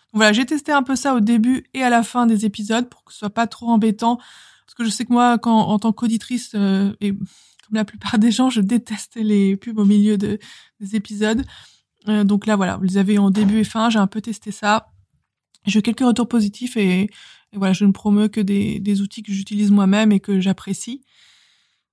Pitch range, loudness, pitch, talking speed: 200-230 Hz, -19 LUFS, 215 Hz, 230 wpm